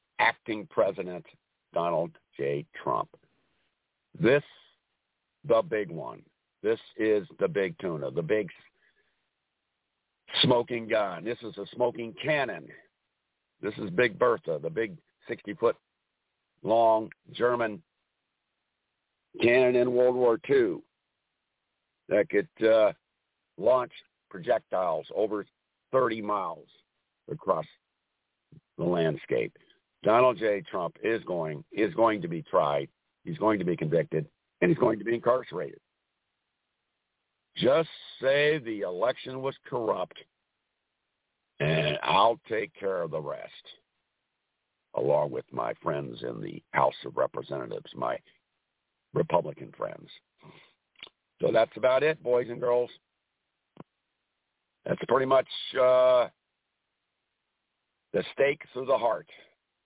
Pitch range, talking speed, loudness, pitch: 110-155 Hz, 110 wpm, -28 LUFS, 125 Hz